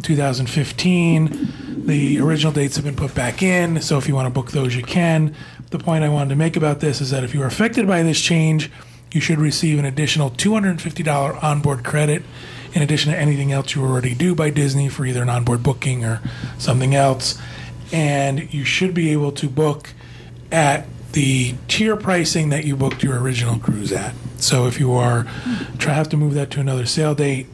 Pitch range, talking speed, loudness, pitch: 130-155 Hz, 200 wpm, -19 LUFS, 145 Hz